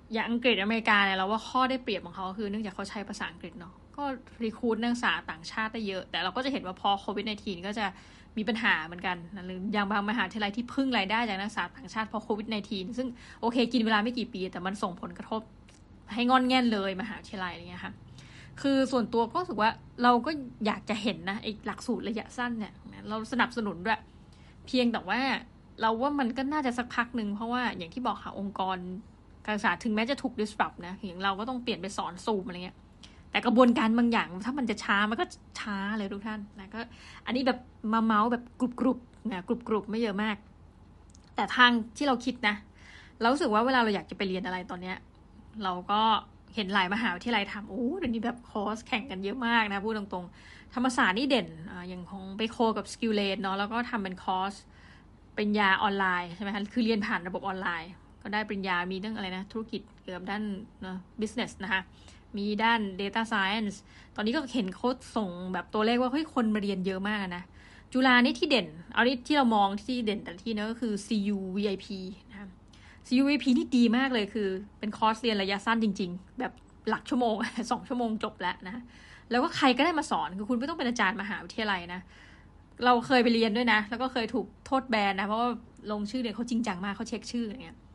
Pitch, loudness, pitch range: 220 Hz, -29 LUFS, 200-240 Hz